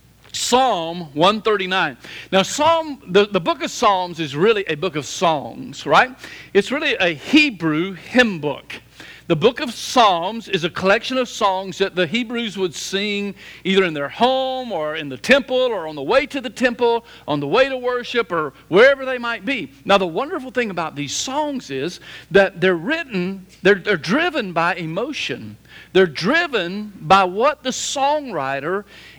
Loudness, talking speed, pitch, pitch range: -19 LUFS, 170 wpm, 200 Hz, 175-255 Hz